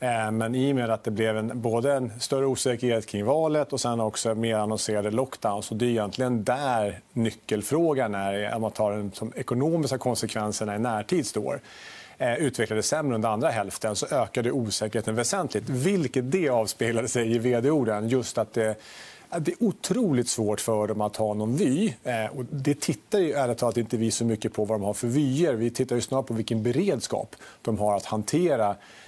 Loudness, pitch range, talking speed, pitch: -26 LUFS, 110-130 Hz, 190 wpm, 115 Hz